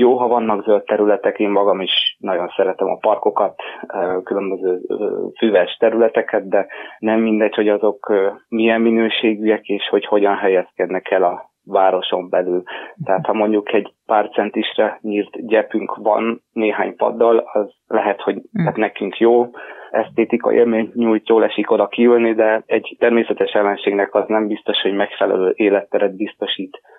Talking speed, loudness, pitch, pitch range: 145 wpm, -17 LUFS, 110 Hz, 100-115 Hz